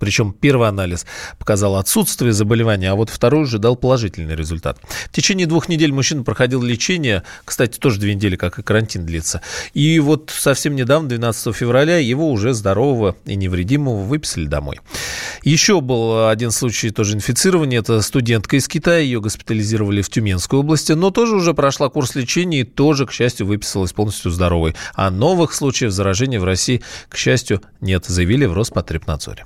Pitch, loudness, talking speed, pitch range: 120 Hz, -17 LUFS, 165 wpm, 100-140 Hz